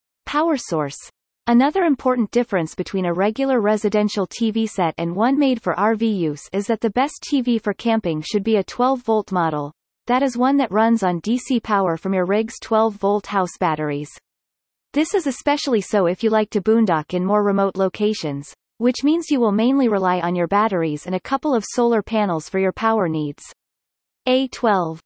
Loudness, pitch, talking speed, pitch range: -20 LUFS, 210 Hz, 185 wpm, 180-240 Hz